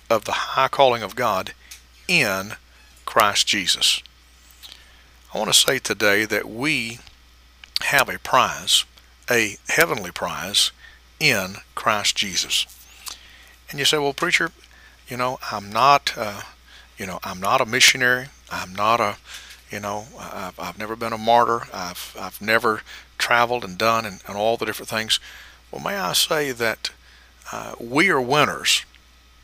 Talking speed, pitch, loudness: 150 wpm, 100 Hz, -20 LUFS